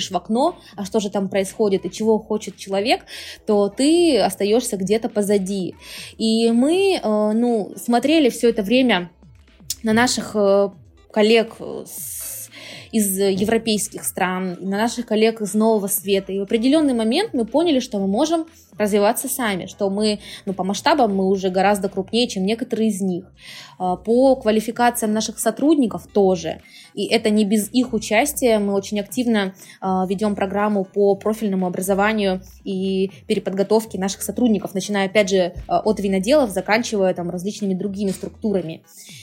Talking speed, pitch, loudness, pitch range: 140 wpm, 210 Hz, -20 LUFS, 195-225 Hz